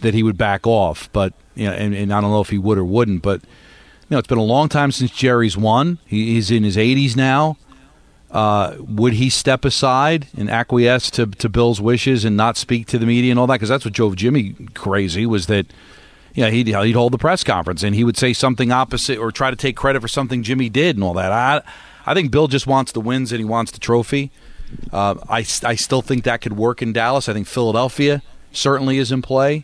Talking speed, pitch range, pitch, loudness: 245 wpm, 110-130 Hz, 120 Hz, -17 LUFS